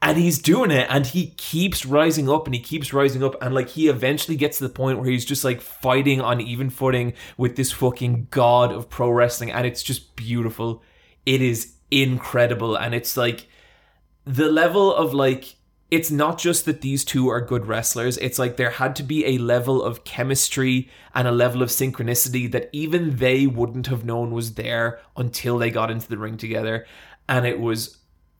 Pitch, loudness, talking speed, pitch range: 125 Hz, -21 LUFS, 195 wpm, 120-140 Hz